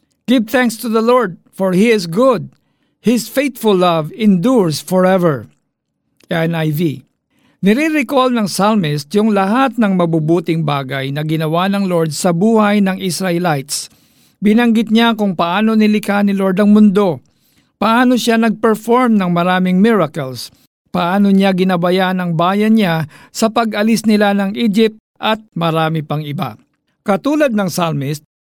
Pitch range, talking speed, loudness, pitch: 170-220 Hz, 135 wpm, -14 LUFS, 195 Hz